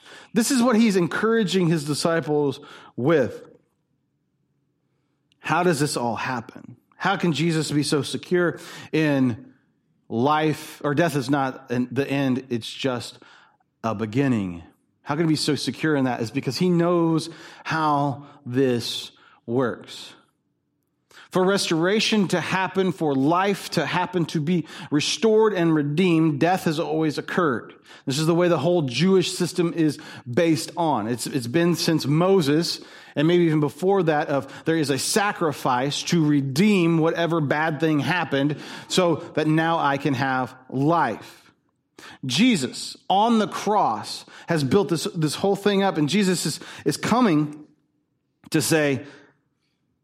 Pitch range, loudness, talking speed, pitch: 145-175 Hz, -22 LUFS, 145 wpm, 155 Hz